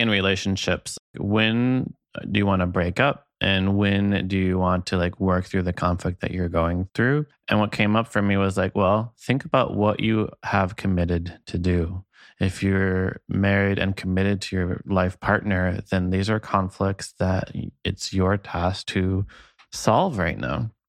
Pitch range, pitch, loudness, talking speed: 90-105 Hz, 95 Hz, -23 LUFS, 180 wpm